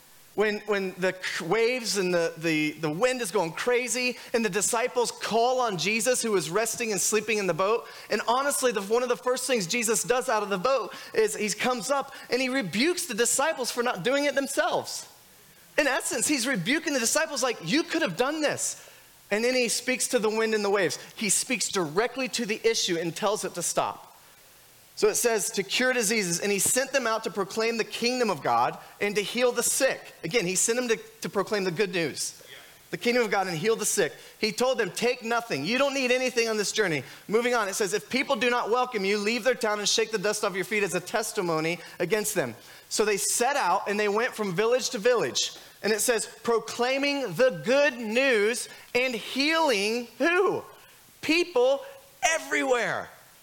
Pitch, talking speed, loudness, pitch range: 230 Hz, 210 wpm, -26 LUFS, 205-255 Hz